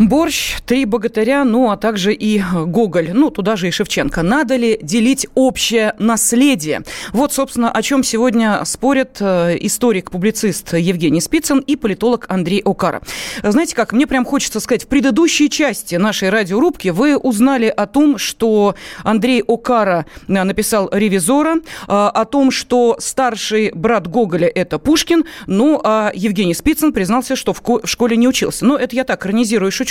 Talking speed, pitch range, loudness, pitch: 150 wpm, 205-260 Hz, -15 LUFS, 230 Hz